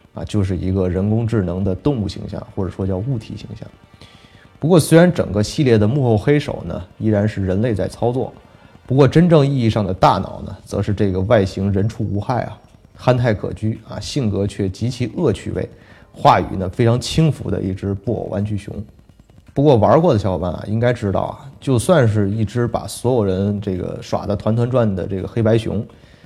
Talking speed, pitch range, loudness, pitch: 295 characters per minute, 100-120 Hz, -18 LUFS, 105 Hz